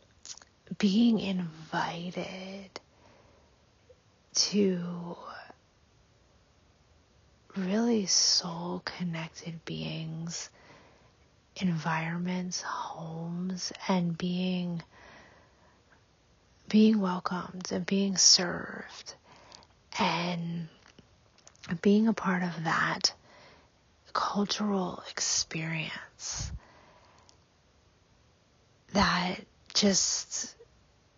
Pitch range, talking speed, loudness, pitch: 165-195 Hz, 50 wpm, -29 LUFS, 180 Hz